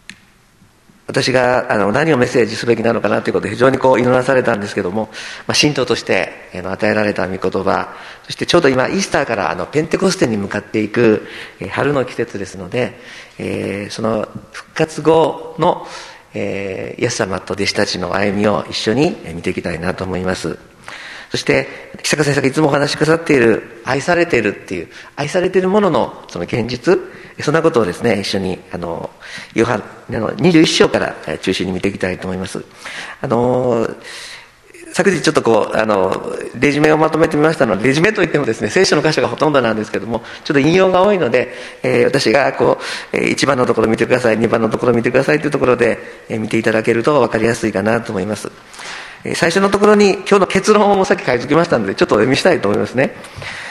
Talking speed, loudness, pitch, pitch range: 420 characters per minute, -15 LUFS, 115 Hz, 100-155 Hz